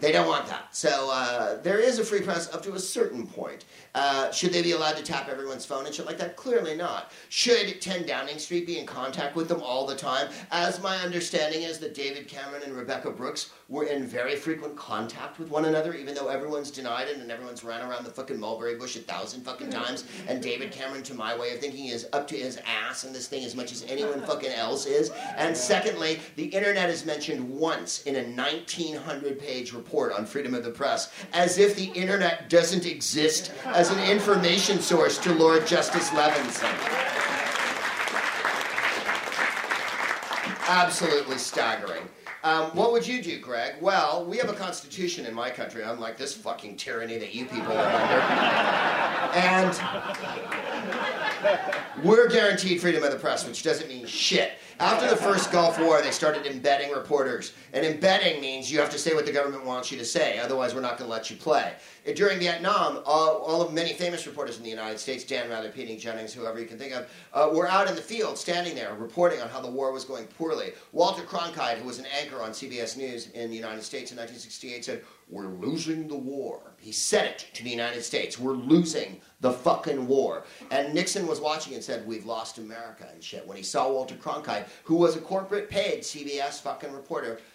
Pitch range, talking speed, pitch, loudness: 130-175 Hz, 200 wpm, 150 Hz, -27 LUFS